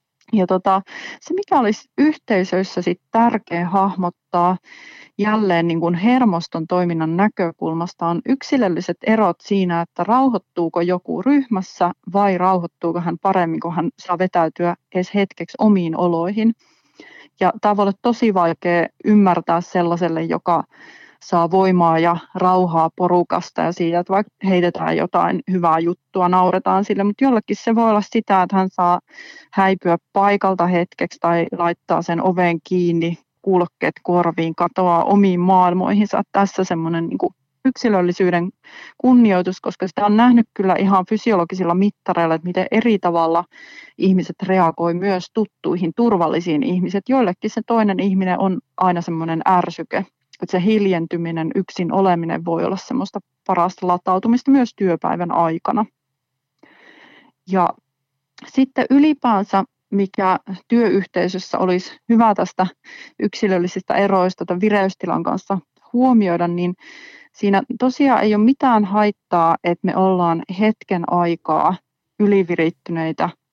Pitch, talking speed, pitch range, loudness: 185 Hz, 125 wpm, 175-210 Hz, -18 LUFS